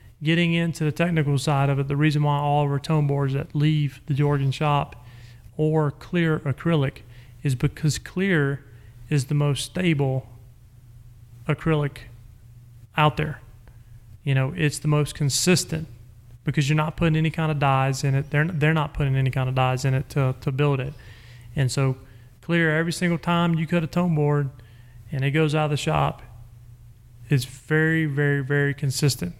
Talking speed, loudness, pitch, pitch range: 175 wpm, -23 LUFS, 140 Hz, 120-155 Hz